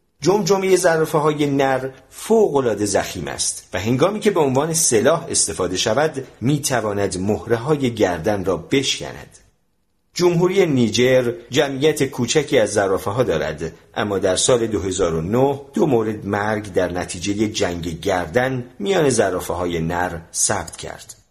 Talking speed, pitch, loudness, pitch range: 130 wpm, 120 Hz, -19 LUFS, 95-140 Hz